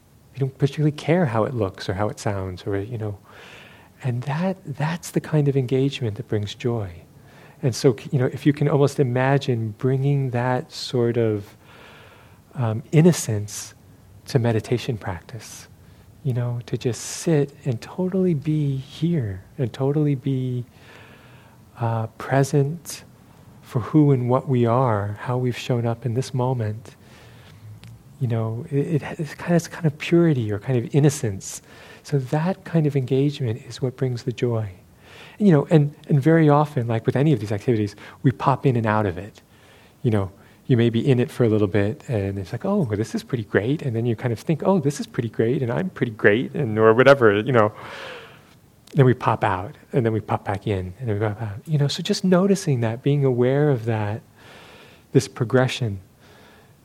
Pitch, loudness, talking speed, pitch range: 125 Hz, -22 LUFS, 190 wpm, 110-140 Hz